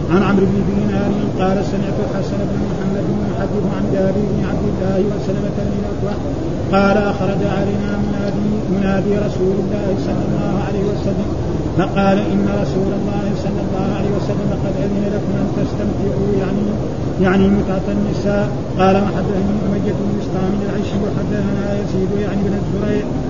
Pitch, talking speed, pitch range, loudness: 190 Hz, 145 wpm, 185-195 Hz, -18 LUFS